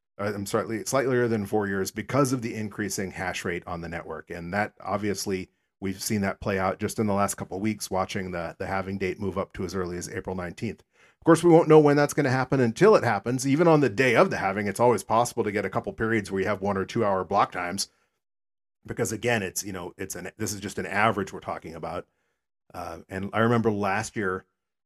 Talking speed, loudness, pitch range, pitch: 250 wpm, -26 LUFS, 95-115 Hz, 100 Hz